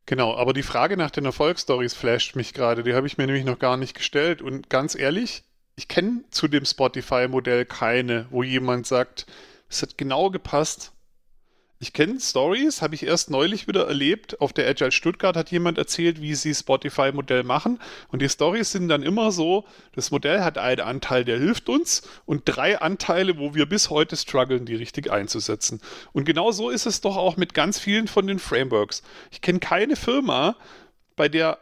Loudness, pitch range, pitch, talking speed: -23 LUFS, 130-190 Hz, 150 Hz, 190 wpm